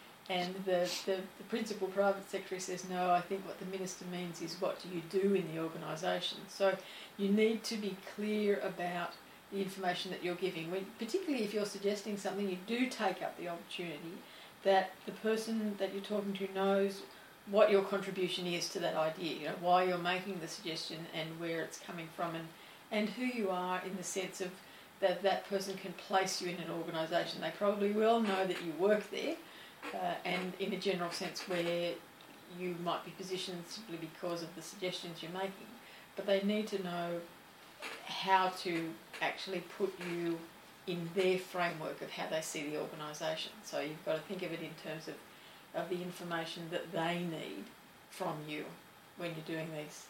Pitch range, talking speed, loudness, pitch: 170-195 Hz, 190 wpm, -37 LUFS, 185 Hz